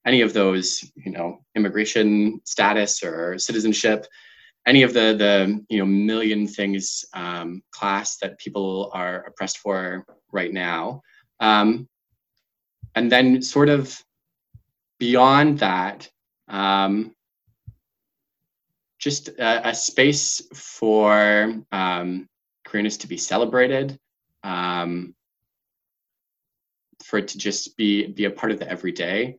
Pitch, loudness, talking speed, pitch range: 105 Hz, -21 LUFS, 115 wpm, 95-115 Hz